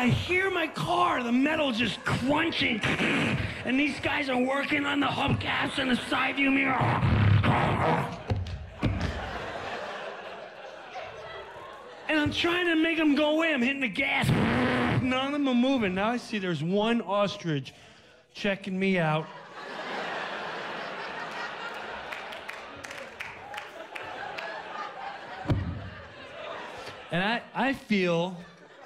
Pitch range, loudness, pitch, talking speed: 170-280 Hz, -27 LUFS, 240 Hz, 105 wpm